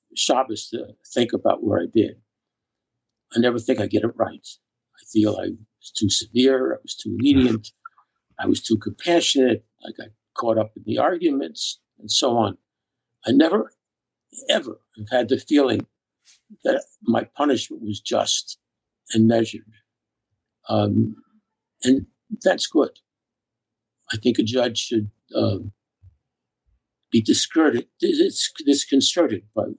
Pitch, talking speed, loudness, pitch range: 115 Hz, 130 wpm, -22 LUFS, 110-130 Hz